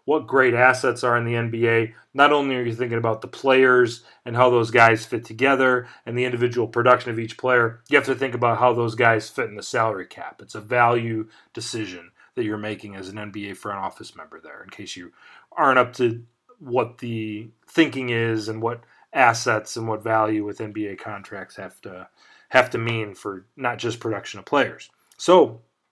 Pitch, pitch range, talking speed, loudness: 115 Hz, 110-125 Hz, 200 wpm, -21 LUFS